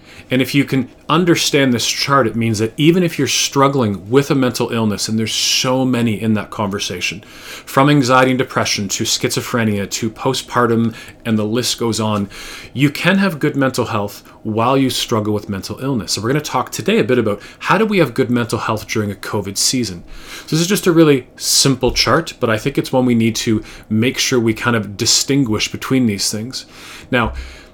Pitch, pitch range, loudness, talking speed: 120 Hz, 110-135 Hz, -16 LUFS, 210 wpm